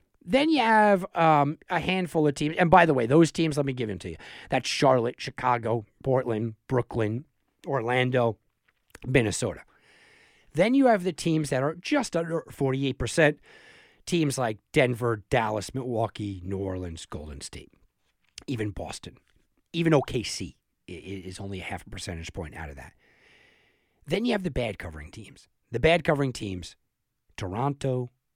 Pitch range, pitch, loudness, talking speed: 105-165 Hz, 130 Hz, -26 LUFS, 150 wpm